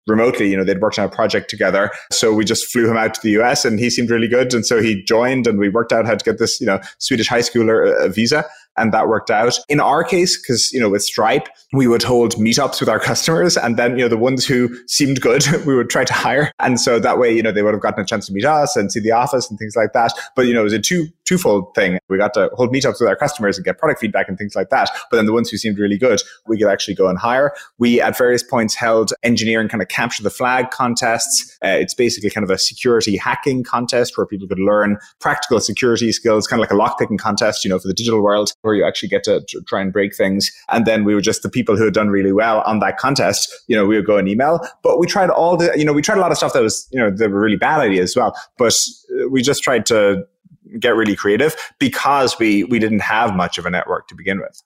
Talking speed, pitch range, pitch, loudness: 275 wpm, 105-125 Hz, 115 Hz, -16 LUFS